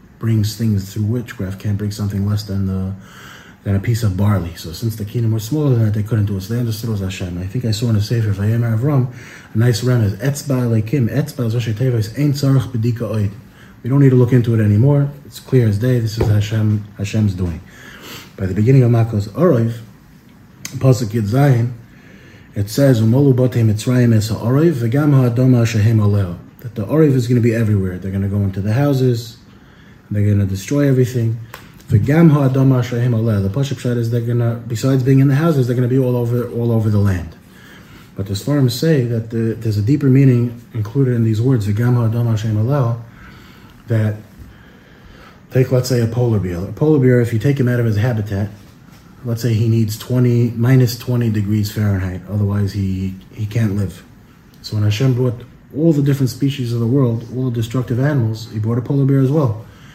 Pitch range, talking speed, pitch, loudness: 105-130 Hz, 185 wpm, 115 Hz, -17 LUFS